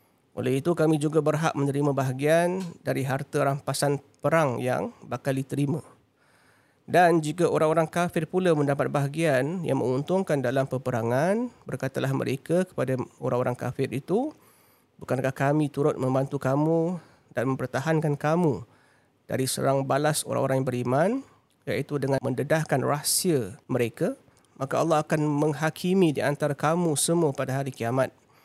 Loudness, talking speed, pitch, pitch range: -26 LUFS, 130 wpm, 145 Hz, 130-160 Hz